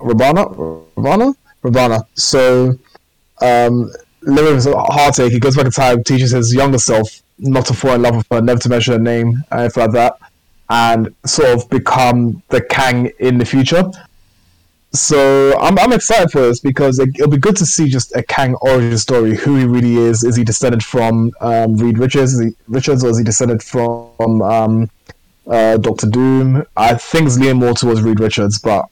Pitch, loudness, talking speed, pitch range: 120 Hz, -13 LUFS, 190 wpm, 115-135 Hz